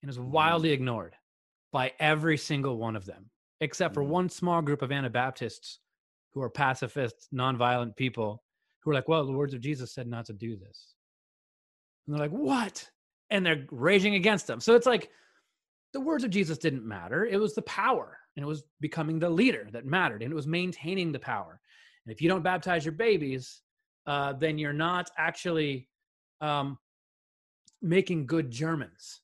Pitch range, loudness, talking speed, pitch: 130-180 Hz, -29 LUFS, 180 wpm, 155 Hz